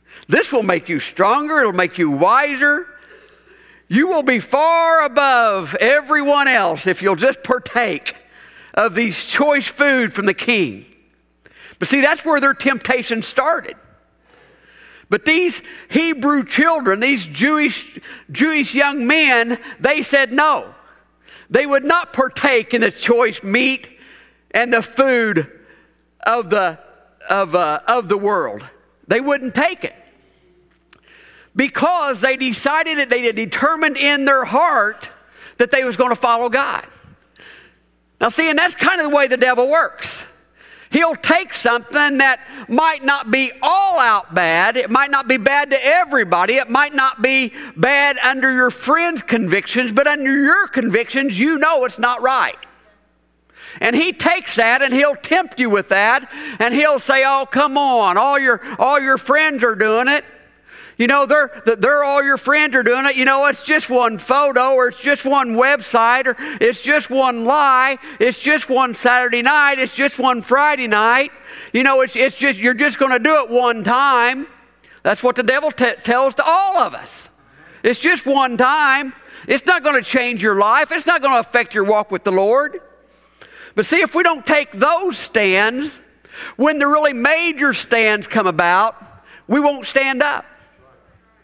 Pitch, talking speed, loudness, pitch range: 270 Hz, 165 wpm, -15 LUFS, 240-295 Hz